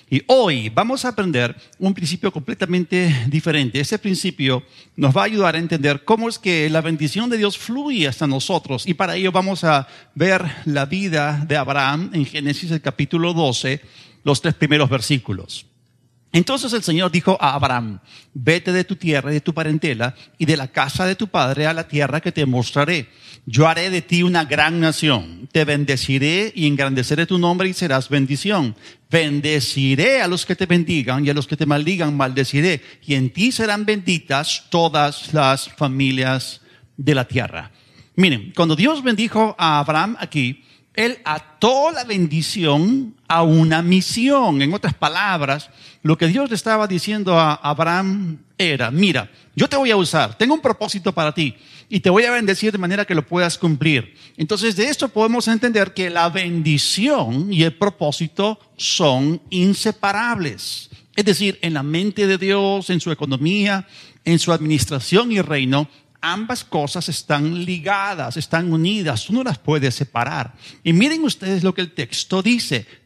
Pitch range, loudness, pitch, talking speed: 140-190 Hz, -18 LUFS, 160 Hz, 170 wpm